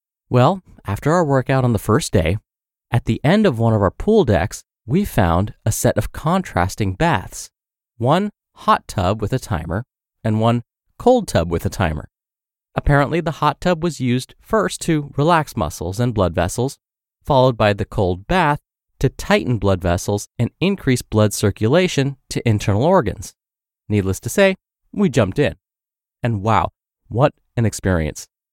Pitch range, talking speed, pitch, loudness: 100-145 Hz, 160 wpm, 120 Hz, -19 LUFS